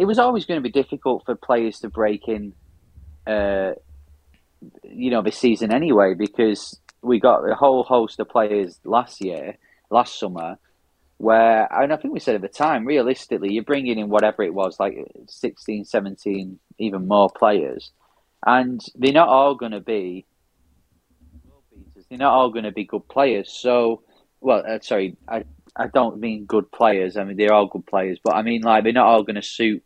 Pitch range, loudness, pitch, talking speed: 95-115 Hz, -20 LUFS, 105 Hz, 185 wpm